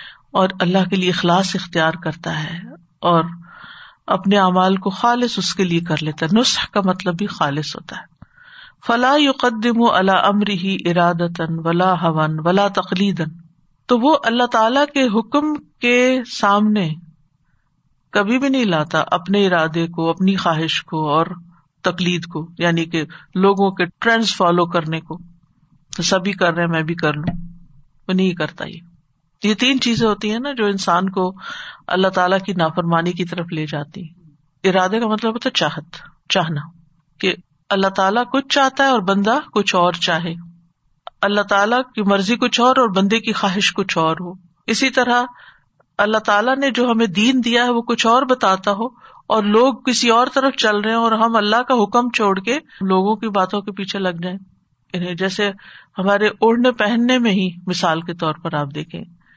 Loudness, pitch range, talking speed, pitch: -17 LUFS, 170-225 Hz, 175 wpm, 190 Hz